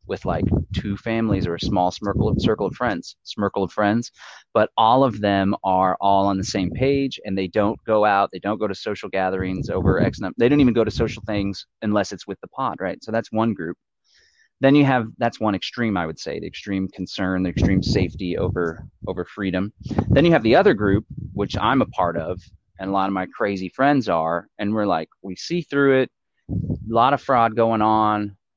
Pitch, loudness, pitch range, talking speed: 100 Hz, -21 LUFS, 95-110 Hz, 225 wpm